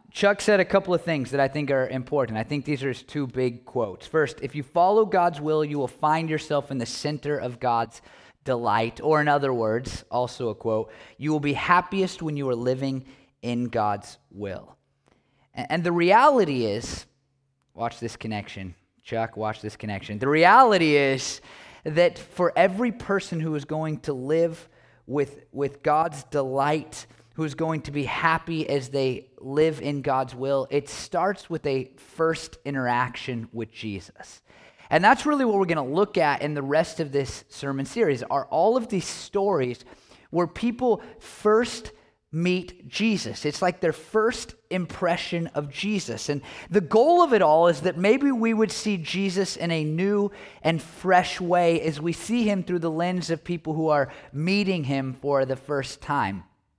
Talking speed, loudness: 175 wpm, -24 LUFS